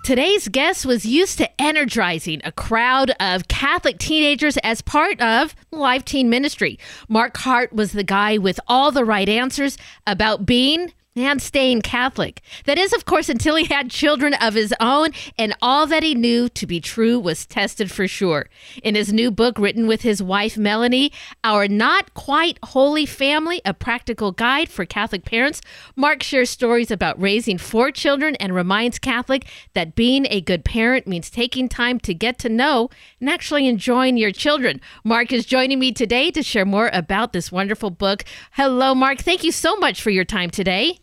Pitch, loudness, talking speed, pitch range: 245 Hz, -18 LUFS, 180 wpm, 210-280 Hz